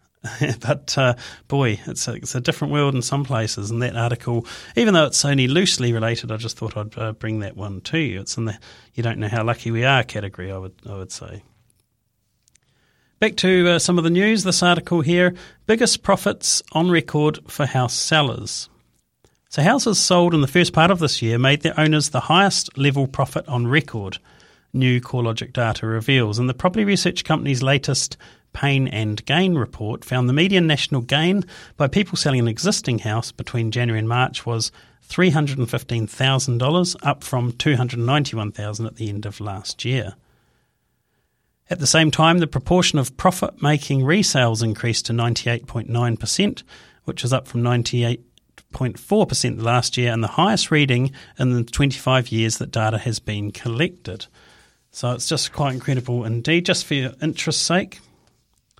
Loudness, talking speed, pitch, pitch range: -20 LUFS, 185 wpm, 130 Hz, 115-155 Hz